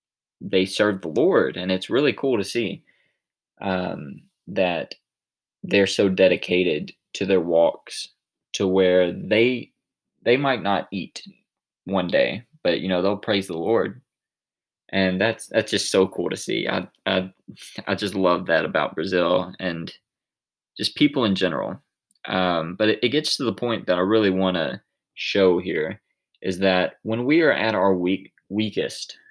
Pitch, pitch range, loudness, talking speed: 95 Hz, 95-110 Hz, -22 LUFS, 160 wpm